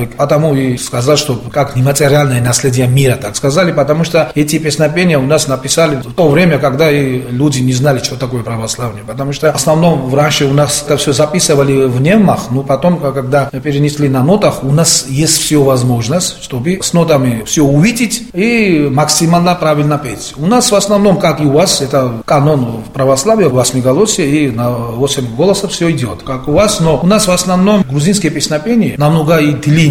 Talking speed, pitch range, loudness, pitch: 190 wpm, 135-165 Hz, -11 LUFS, 145 Hz